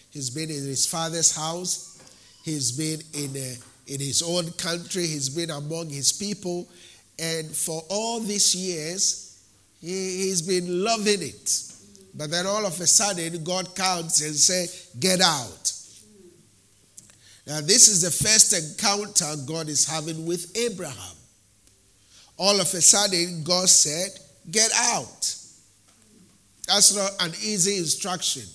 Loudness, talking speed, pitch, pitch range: -21 LUFS, 130 wpm, 165 Hz, 140-185 Hz